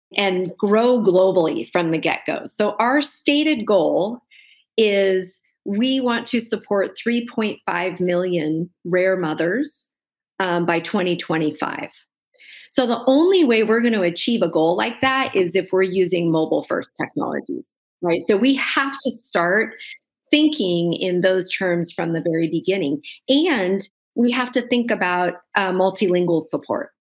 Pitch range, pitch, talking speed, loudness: 180-255 Hz, 200 Hz, 145 wpm, -20 LUFS